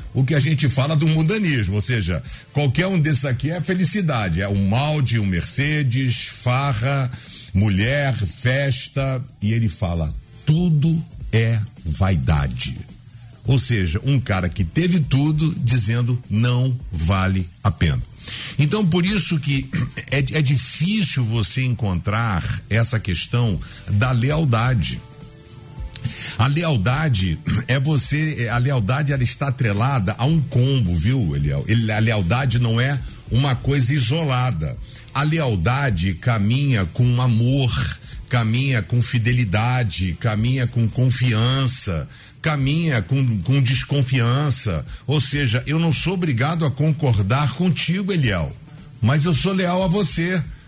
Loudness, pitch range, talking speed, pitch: -20 LUFS, 110-145 Hz, 125 wpm, 125 Hz